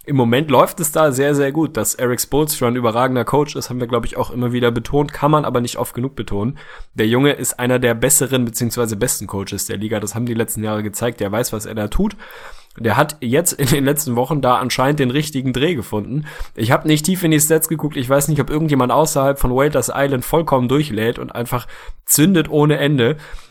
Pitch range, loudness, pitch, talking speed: 120-150 Hz, -17 LUFS, 130 Hz, 230 wpm